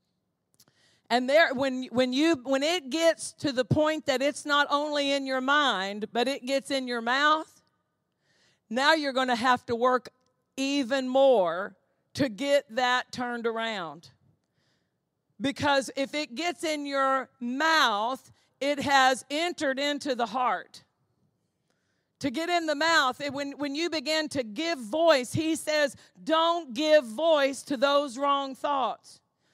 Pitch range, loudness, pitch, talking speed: 255-305 Hz, -26 LUFS, 280 Hz, 150 wpm